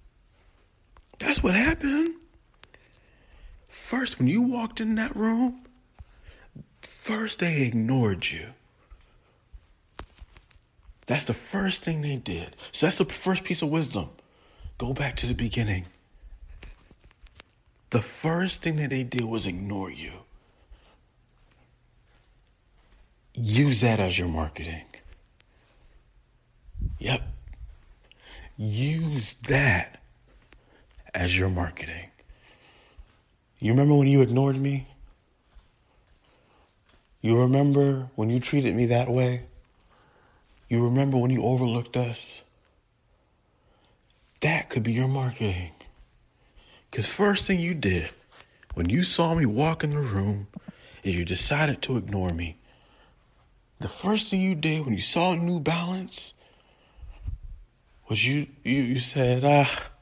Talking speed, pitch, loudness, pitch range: 110 wpm, 125 Hz, -26 LUFS, 95-150 Hz